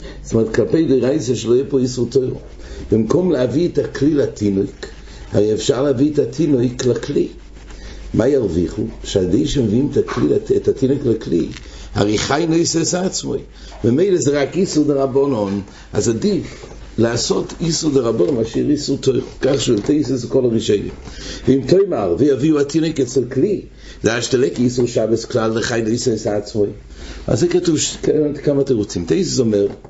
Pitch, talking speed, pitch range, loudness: 135 Hz, 135 wpm, 115-150 Hz, -17 LUFS